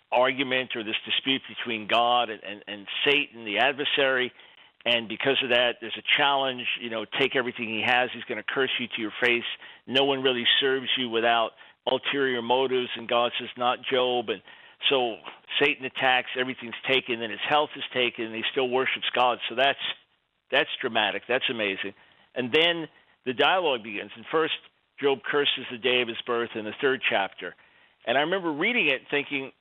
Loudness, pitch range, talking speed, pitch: -25 LUFS, 115-135 Hz, 185 wpm, 125 Hz